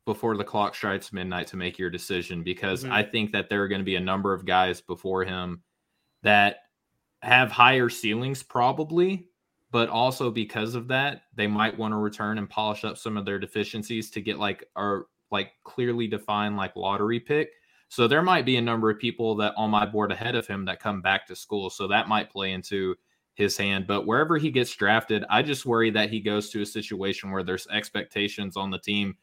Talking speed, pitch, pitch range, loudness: 210 wpm, 105 Hz, 95-115 Hz, -26 LUFS